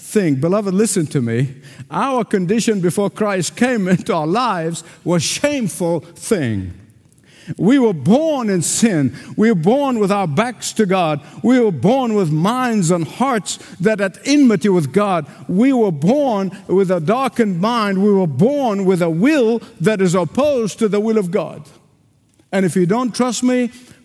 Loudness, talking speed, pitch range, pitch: -17 LUFS, 170 wpm, 170-230 Hz, 200 Hz